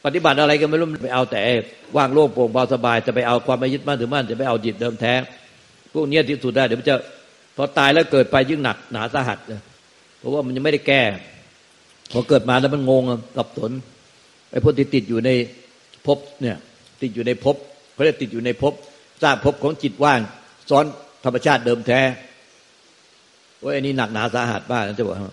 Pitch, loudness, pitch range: 130 Hz, -20 LUFS, 120-145 Hz